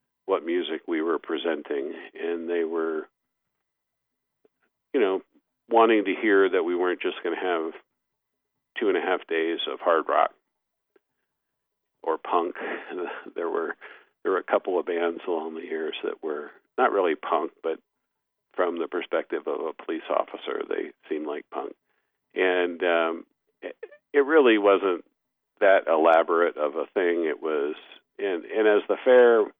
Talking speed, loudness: 155 wpm, -25 LUFS